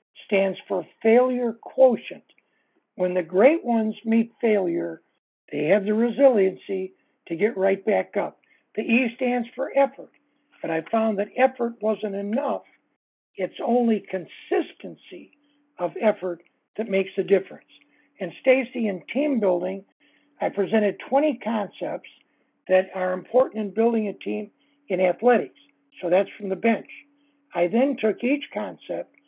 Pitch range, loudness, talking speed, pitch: 190-260 Hz, -24 LUFS, 140 wpm, 220 Hz